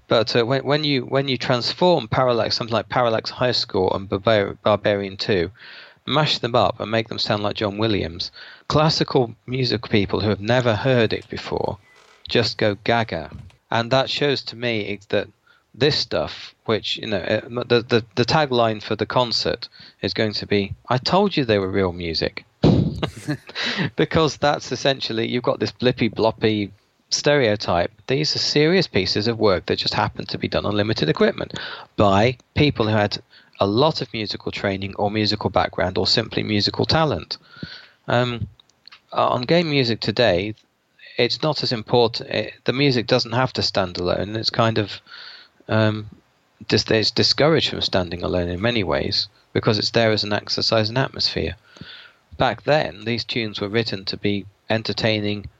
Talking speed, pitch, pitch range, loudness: 170 wpm, 110 Hz, 105-125 Hz, -21 LUFS